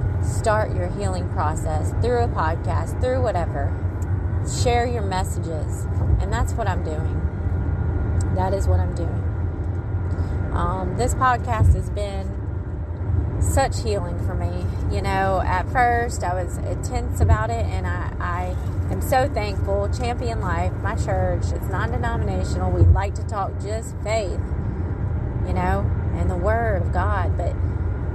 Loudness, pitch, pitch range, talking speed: -23 LUFS, 95 Hz, 90-100 Hz, 145 wpm